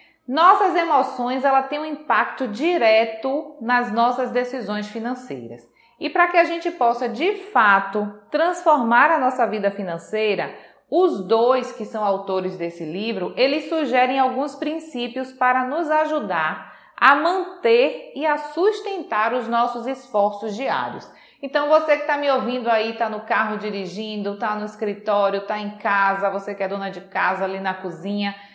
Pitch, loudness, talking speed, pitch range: 245 Hz, -21 LUFS, 155 wpm, 205-300 Hz